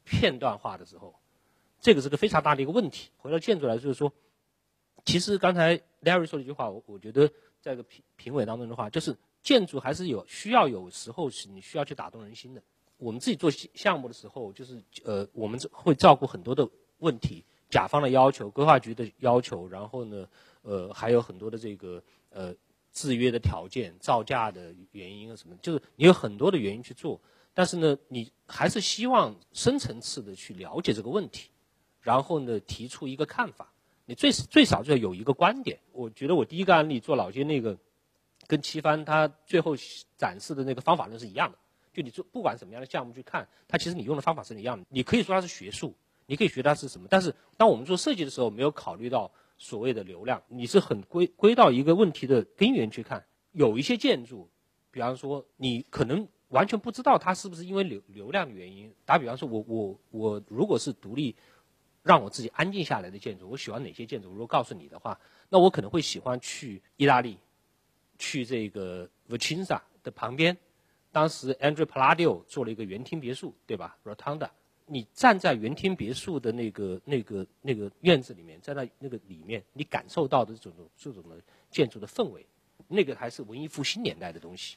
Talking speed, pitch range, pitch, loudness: 330 characters per minute, 115-170 Hz, 135 Hz, -27 LUFS